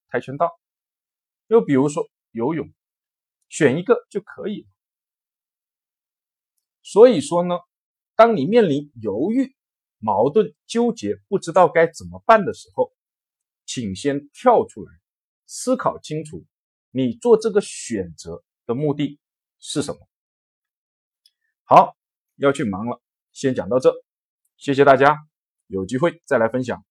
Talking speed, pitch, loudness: 180 characters per minute, 175 Hz, -20 LUFS